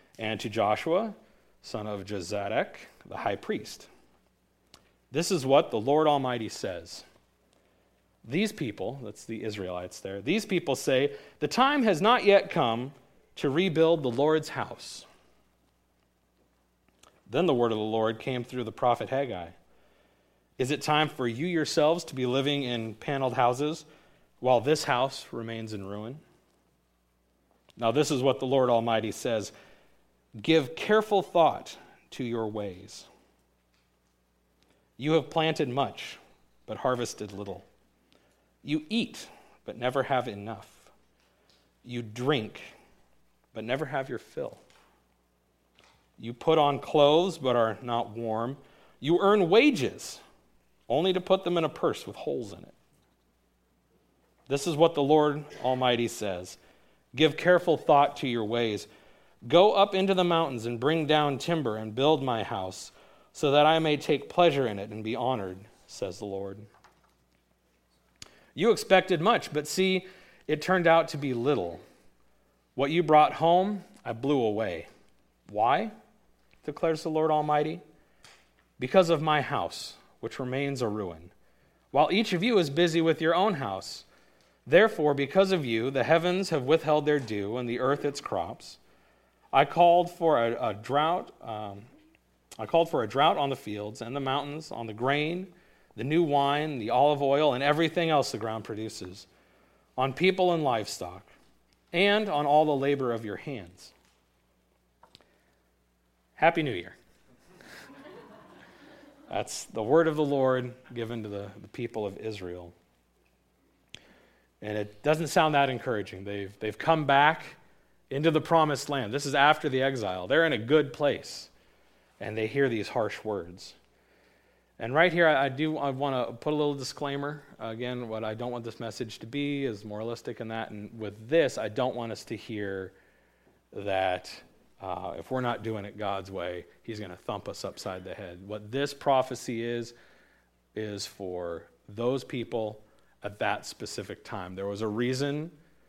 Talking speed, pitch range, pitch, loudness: 155 wpm, 100-150 Hz, 125 Hz, -28 LUFS